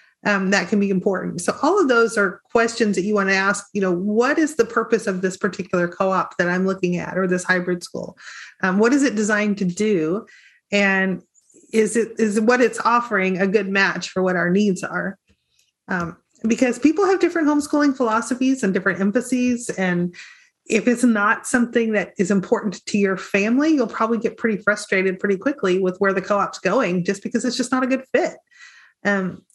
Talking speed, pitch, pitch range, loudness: 200 wpm, 205 Hz, 190-235 Hz, -20 LUFS